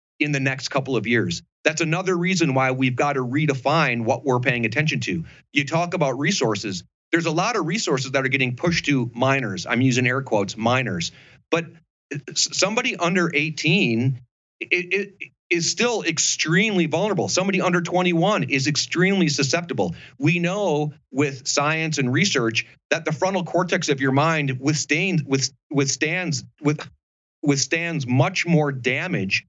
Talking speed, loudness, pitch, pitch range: 150 wpm, -21 LUFS, 150 Hz, 130-170 Hz